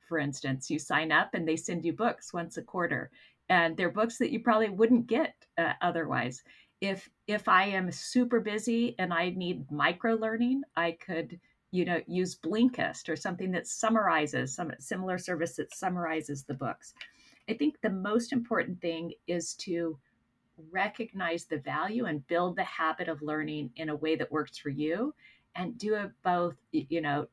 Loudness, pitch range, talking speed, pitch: -31 LUFS, 160-220 Hz, 180 wpm, 175 Hz